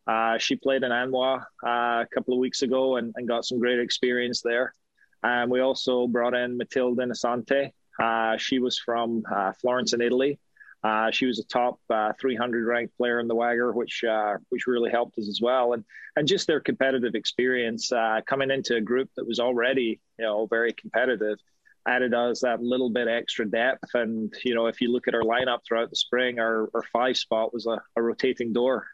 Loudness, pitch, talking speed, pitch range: -26 LUFS, 120 Hz, 205 wpm, 115-125 Hz